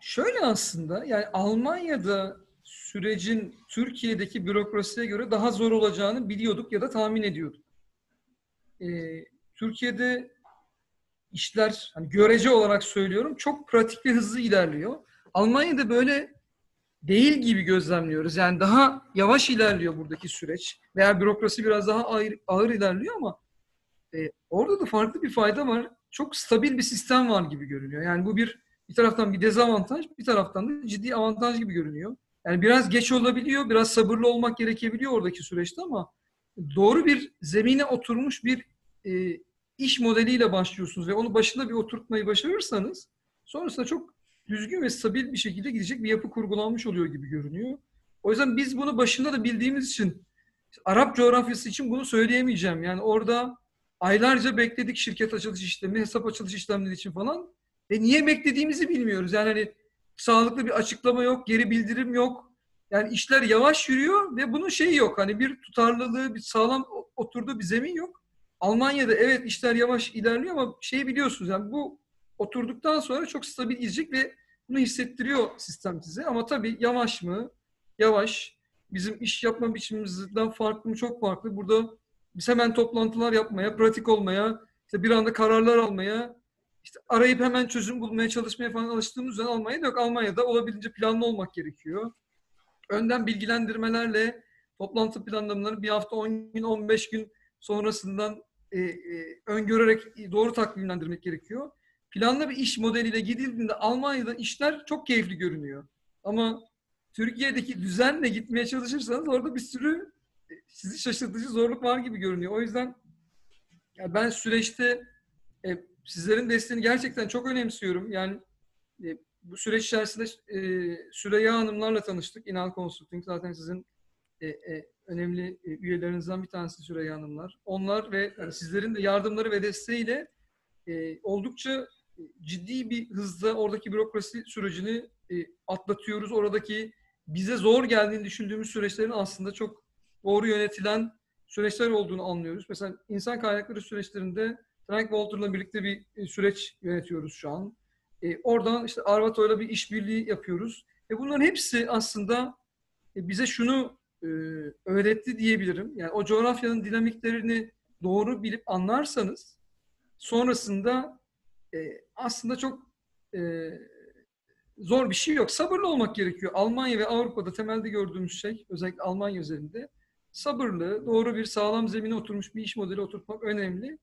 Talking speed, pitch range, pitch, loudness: 135 wpm, 200-245 Hz, 220 Hz, -27 LUFS